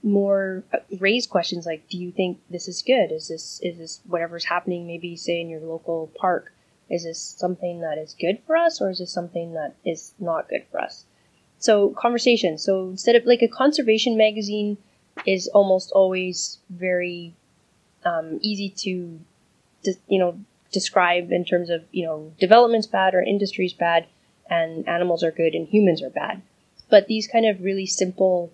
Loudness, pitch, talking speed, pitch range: -22 LUFS, 185 Hz, 175 wpm, 170-205 Hz